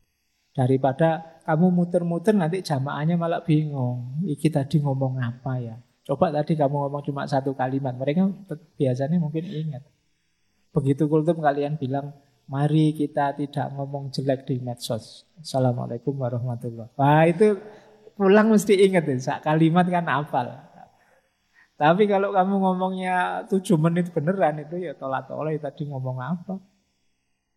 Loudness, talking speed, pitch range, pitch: -23 LUFS, 130 wpm, 135-175 Hz, 150 Hz